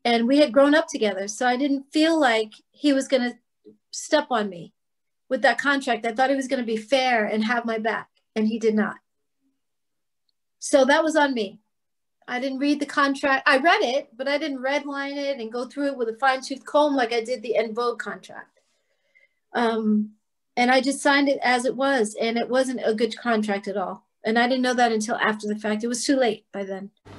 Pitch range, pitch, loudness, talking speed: 225-275 Hz, 250 Hz, -23 LUFS, 225 wpm